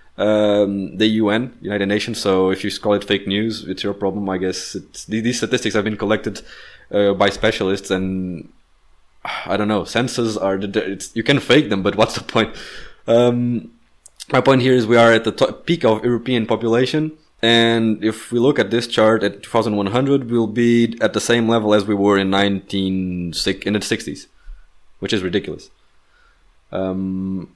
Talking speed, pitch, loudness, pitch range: 180 wpm, 105 Hz, -18 LUFS, 95-115 Hz